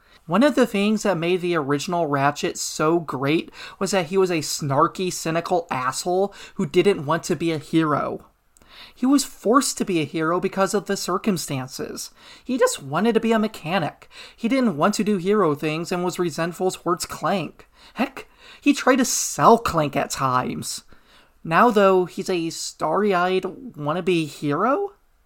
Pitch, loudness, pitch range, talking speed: 185 Hz, -22 LUFS, 165-210 Hz, 170 wpm